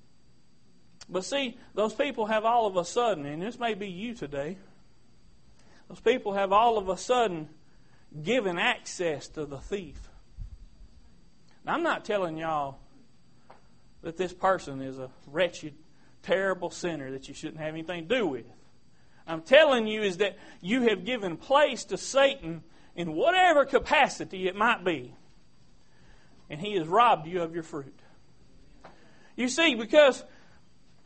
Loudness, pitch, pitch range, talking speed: -27 LUFS, 185 Hz, 155-230 Hz, 145 wpm